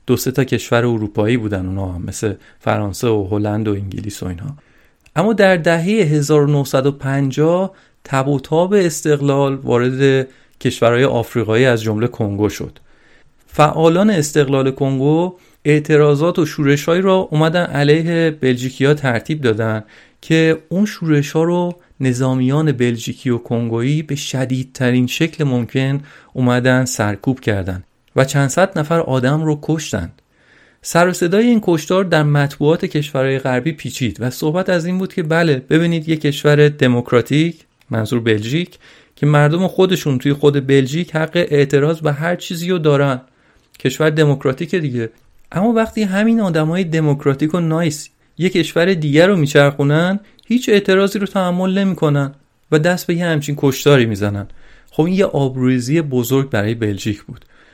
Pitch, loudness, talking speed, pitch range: 145 Hz, -16 LUFS, 145 wpm, 125-165 Hz